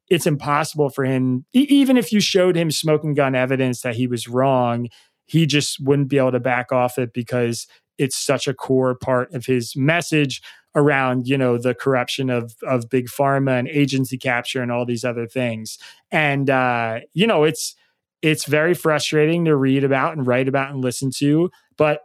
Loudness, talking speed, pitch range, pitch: -19 LUFS, 190 wpm, 125-150 Hz, 135 Hz